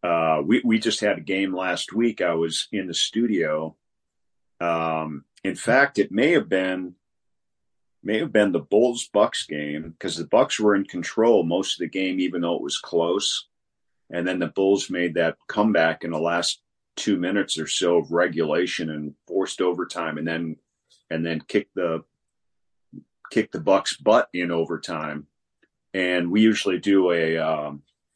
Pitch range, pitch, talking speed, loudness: 80-95 Hz, 85 Hz, 170 wpm, -23 LUFS